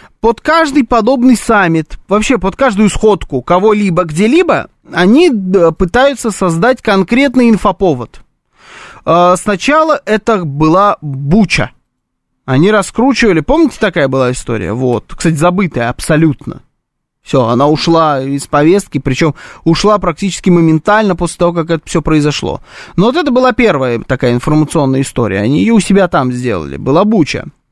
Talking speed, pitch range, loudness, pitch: 130 wpm, 150-220 Hz, -11 LUFS, 180 Hz